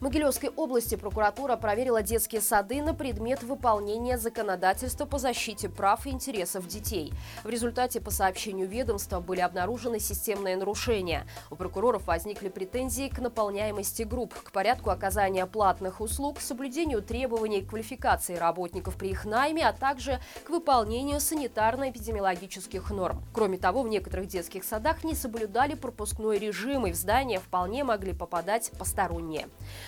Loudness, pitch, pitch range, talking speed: -30 LUFS, 225 Hz, 195-260 Hz, 140 wpm